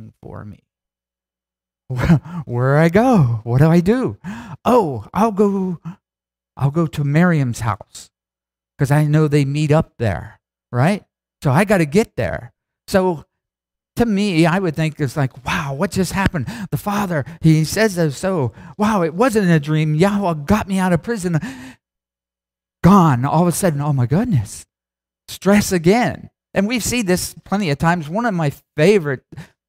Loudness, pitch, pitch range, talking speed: -17 LUFS, 160 Hz, 125-190 Hz, 165 wpm